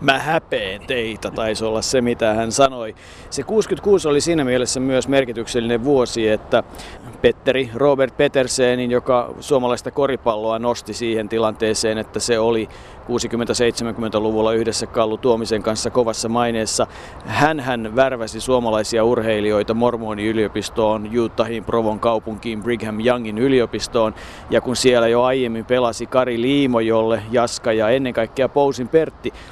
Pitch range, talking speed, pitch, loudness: 110-125 Hz, 130 wpm, 115 Hz, -19 LUFS